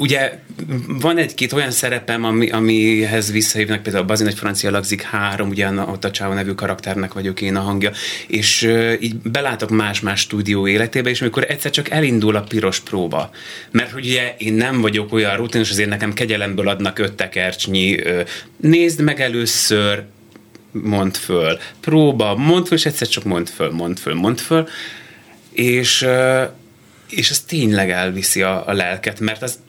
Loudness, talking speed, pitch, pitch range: -17 LUFS, 165 wpm, 110 Hz, 100-125 Hz